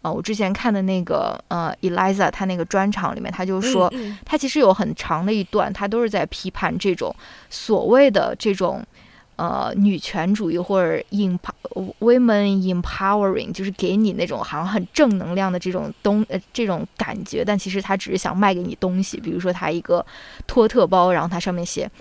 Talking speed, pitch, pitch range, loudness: 335 characters per minute, 195 Hz, 185-210 Hz, -21 LUFS